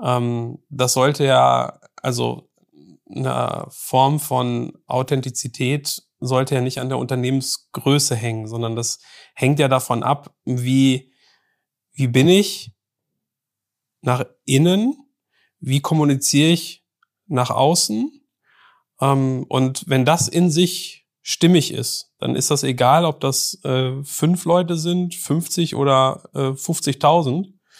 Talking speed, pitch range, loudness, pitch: 110 wpm, 130-165 Hz, -19 LUFS, 135 Hz